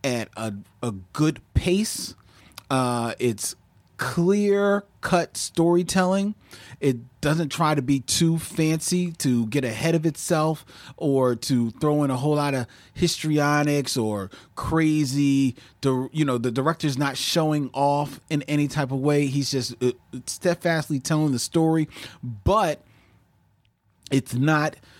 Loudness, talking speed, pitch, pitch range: -24 LUFS, 135 wpm, 140 Hz, 125-160 Hz